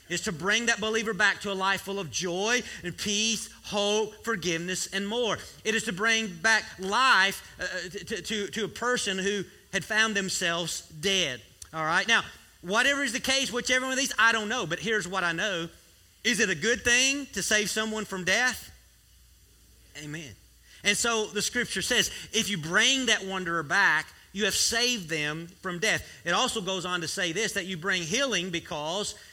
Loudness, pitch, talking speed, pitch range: -26 LUFS, 205 Hz, 190 wpm, 180-225 Hz